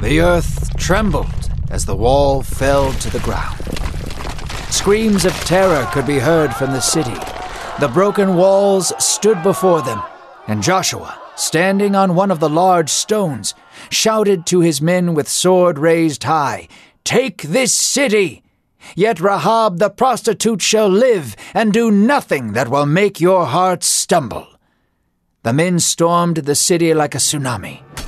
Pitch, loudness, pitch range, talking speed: 175 Hz, -15 LUFS, 145-200 Hz, 145 wpm